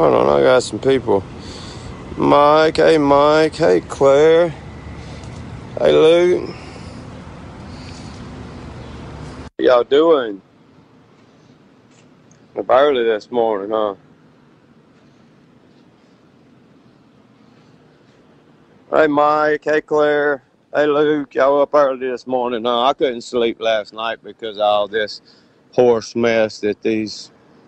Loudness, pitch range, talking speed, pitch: -16 LUFS, 110-150 Hz, 100 wpm, 125 Hz